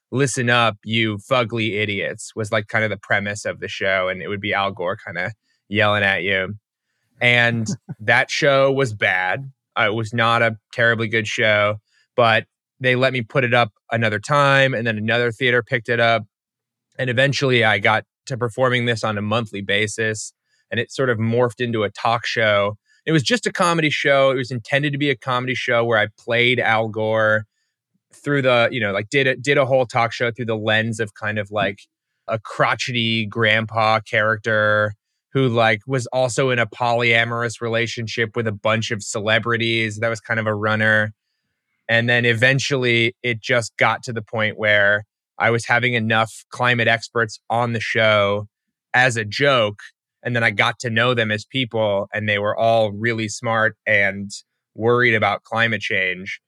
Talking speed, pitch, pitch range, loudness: 185 wpm, 115 Hz, 110-125 Hz, -19 LUFS